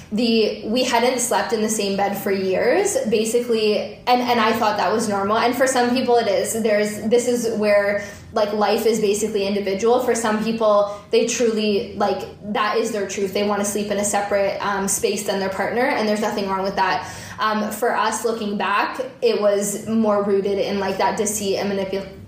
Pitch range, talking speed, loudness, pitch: 200-230 Hz, 205 wpm, -20 LUFS, 210 Hz